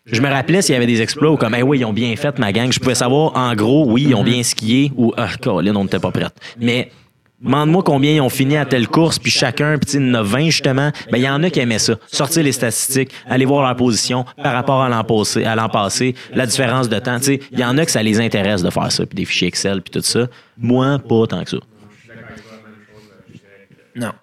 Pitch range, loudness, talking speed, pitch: 115-140 Hz, -16 LUFS, 265 wpm, 125 Hz